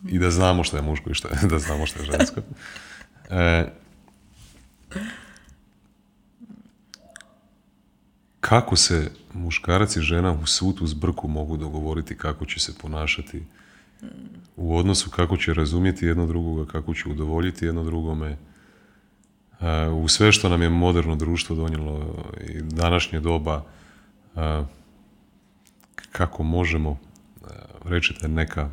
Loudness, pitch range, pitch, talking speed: -23 LUFS, 80-90 Hz, 85 Hz, 115 wpm